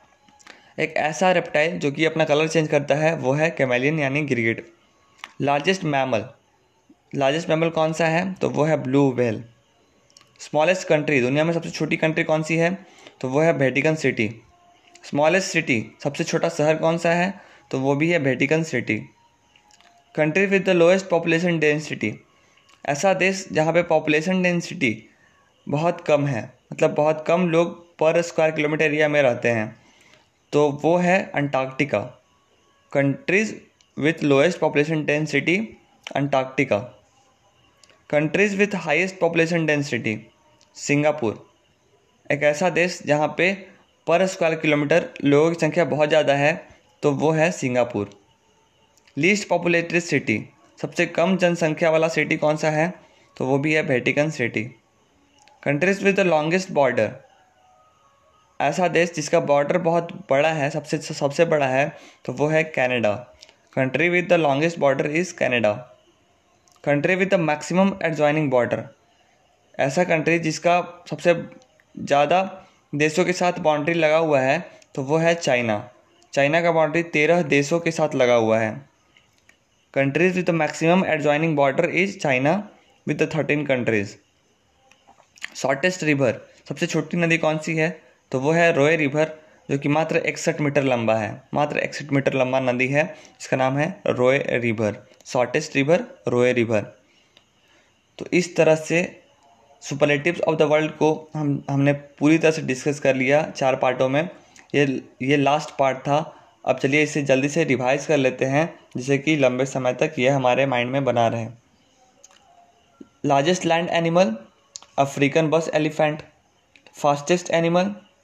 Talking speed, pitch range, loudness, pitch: 150 wpm, 140-170 Hz, -21 LUFS, 155 Hz